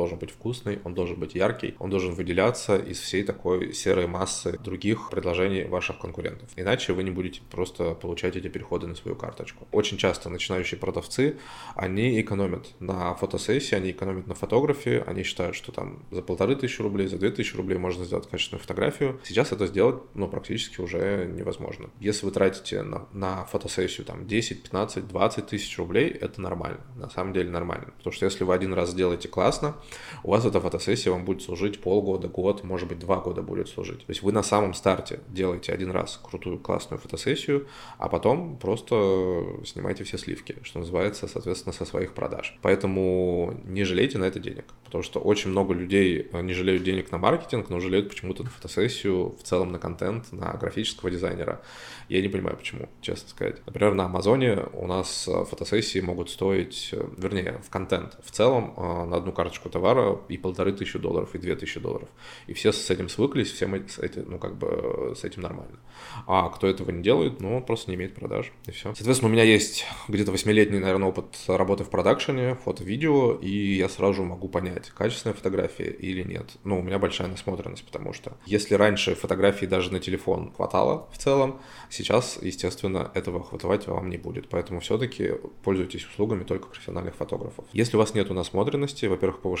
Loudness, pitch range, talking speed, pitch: -27 LUFS, 90-105 Hz, 185 wpm, 95 Hz